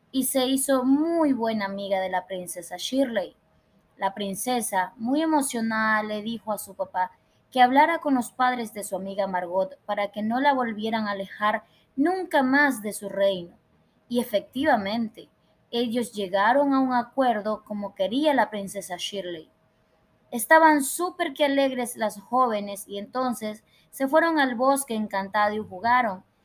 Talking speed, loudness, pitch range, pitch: 150 wpm, -25 LUFS, 200-270 Hz, 230 Hz